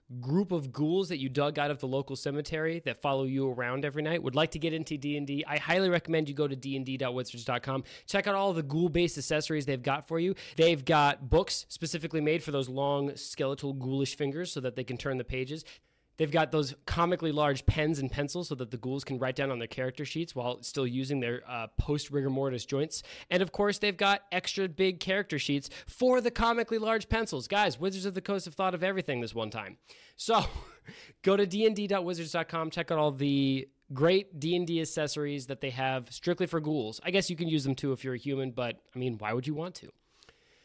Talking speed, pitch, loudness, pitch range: 220 wpm, 150 Hz, -31 LUFS, 135-175 Hz